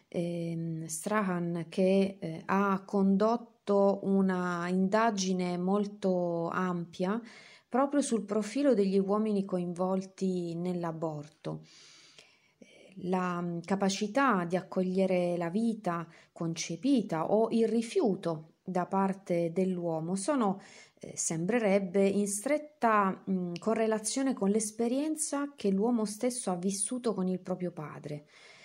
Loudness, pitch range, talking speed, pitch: -31 LUFS, 175-215 Hz, 100 wpm, 195 Hz